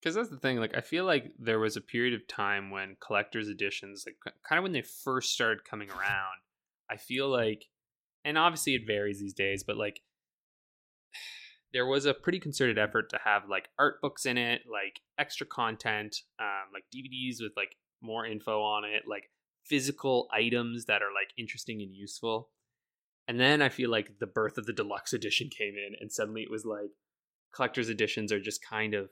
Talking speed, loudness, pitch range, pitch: 195 wpm, -32 LUFS, 105-125 Hz, 110 Hz